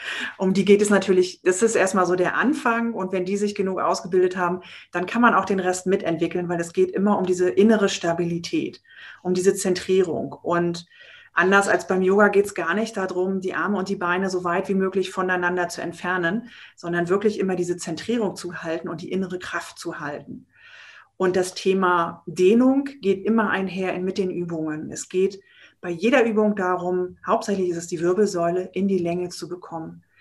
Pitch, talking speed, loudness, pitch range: 185 Hz, 195 wpm, -22 LUFS, 175-200 Hz